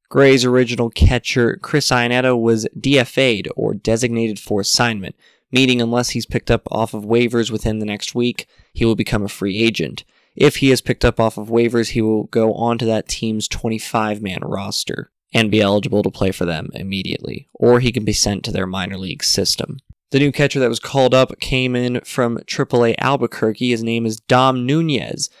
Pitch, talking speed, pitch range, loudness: 115 Hz, 190 wpm, 110-125 Hz, -17 LUFS